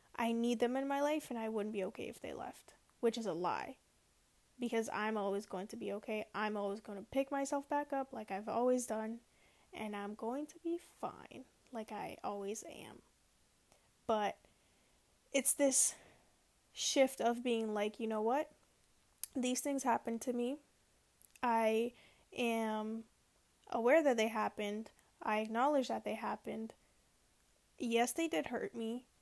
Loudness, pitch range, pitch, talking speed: -38 LUFS, 215-265 Hz, 230 Hz, 160 wpm